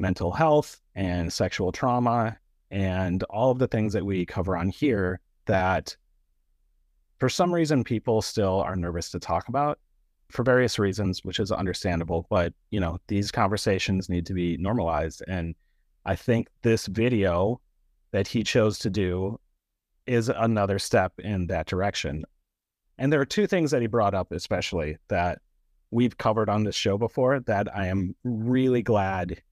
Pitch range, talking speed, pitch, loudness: 90-115 Hz, 160 wpm, 100 Hz, -26 LUFS